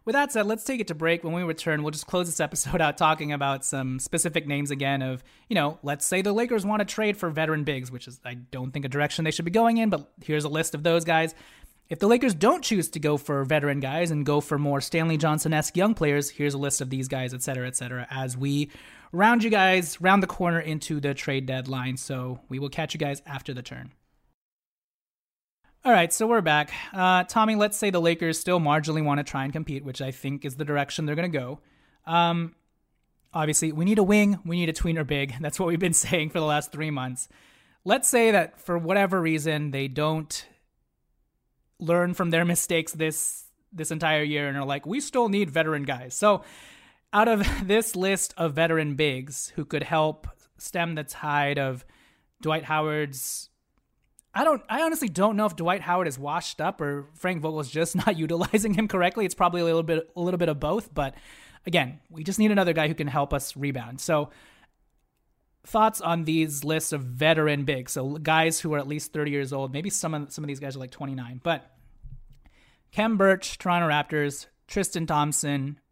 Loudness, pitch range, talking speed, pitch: -25 LUFS, 145-175 Hz, 215 wpm, 155 Hz